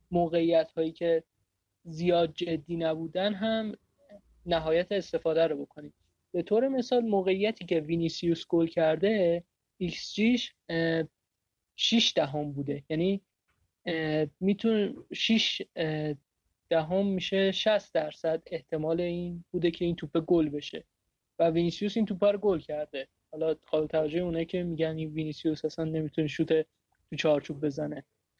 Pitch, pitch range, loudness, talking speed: 165 Hz, 155-185 Hz, -29 LUFS, 130 wpm